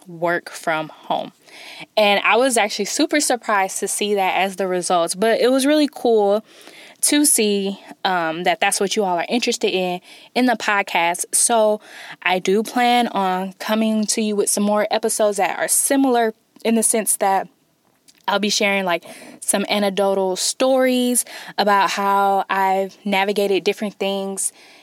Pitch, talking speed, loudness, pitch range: 205 Hz, 160 wpm, -19 LUFS, 195-225 Hz